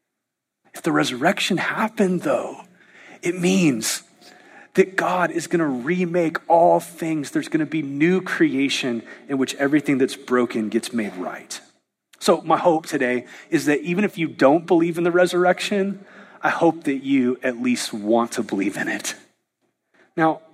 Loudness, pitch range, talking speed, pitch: -21 LUFS, 140-190 Hz, 160 wpm, 165 Hz